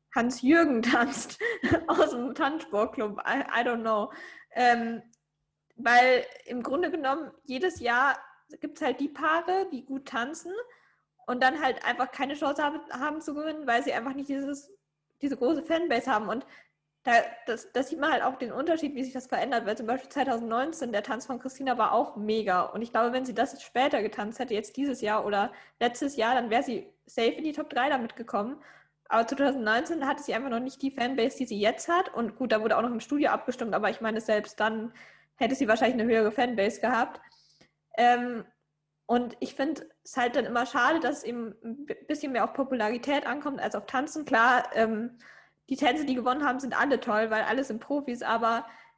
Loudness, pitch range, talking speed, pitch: -28 LUFS, 230-275 Hz, 195 wpm, 245 Hz